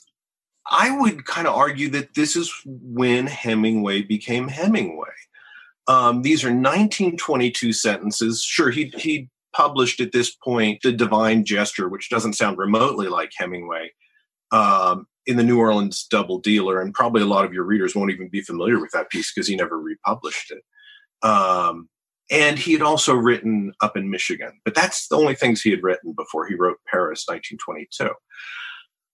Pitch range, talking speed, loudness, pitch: 105-150 Hz, 165 wpm, -20 LUFS, 120 Hz